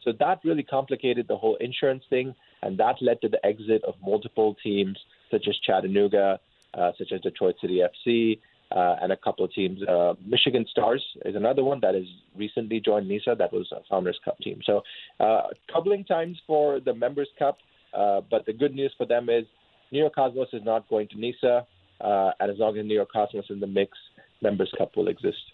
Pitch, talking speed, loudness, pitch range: 115 Hz, 210 wpm, -26 LUFS, 100-135 Hz